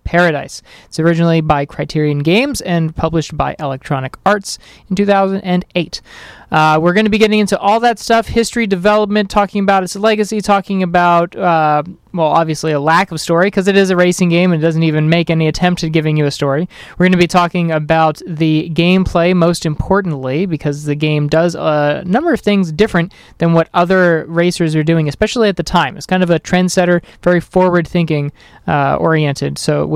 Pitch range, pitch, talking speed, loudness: 155-190 Hz, 170 Hz, 195 wpm, -13 LUFS